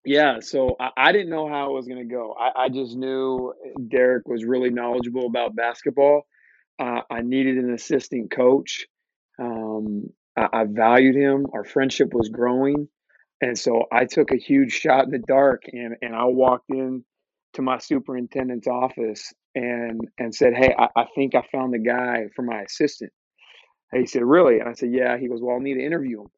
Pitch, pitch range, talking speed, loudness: 125 Hz, 120-135 Hz, 195 wpm, -22 LUFS